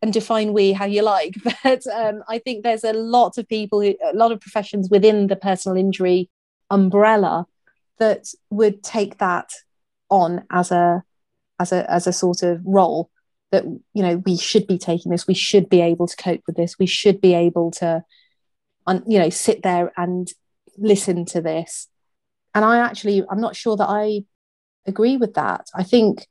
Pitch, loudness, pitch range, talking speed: 195 Hz, -19 LUFS, 180-220 Hz, 185 wpm